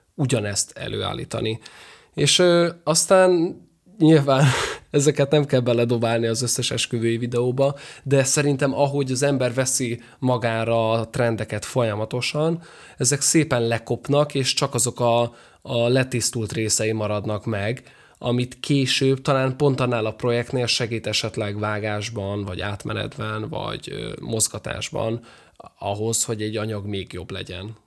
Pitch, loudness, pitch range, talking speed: 120 Hz, -22 LUFS, 110-140 Hz, 125 wpm